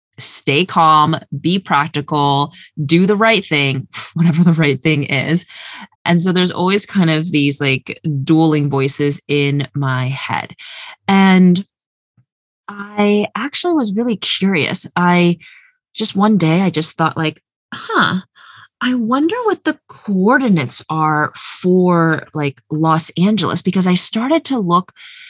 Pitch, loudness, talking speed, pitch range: 175 Hz, -15 LUFS, 135 wpm, 150-205 Hz